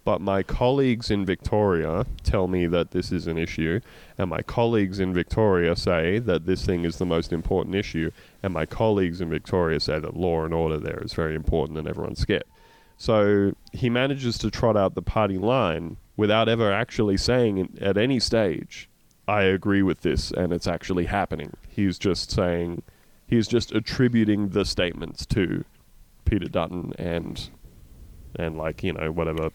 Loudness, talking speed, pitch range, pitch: -25 LUFS, 170 wpm, 85-110 Hz, 95 Hz